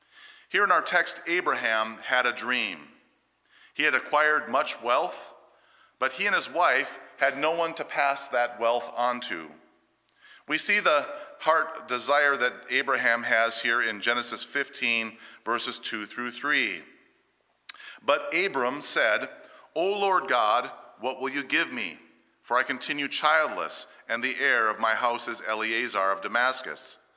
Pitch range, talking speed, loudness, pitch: 115-140 Hz, 150 wpm, -25 LUFS, 120 Hz